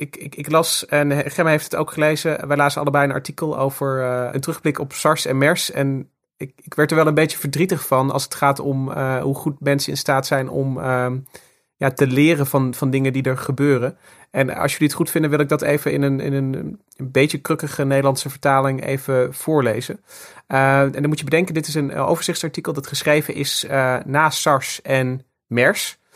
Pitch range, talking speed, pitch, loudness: 135-155 Hz, 215 wpm, 140 Hz, -19 LUFS